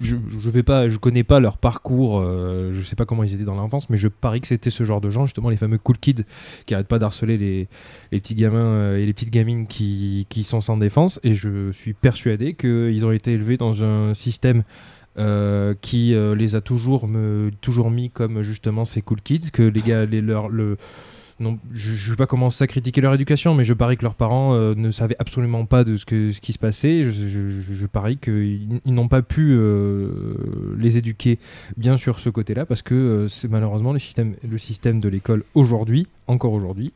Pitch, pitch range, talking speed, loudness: 115 Hz, 105-125 Hz, 220 wpm, -20 LUFS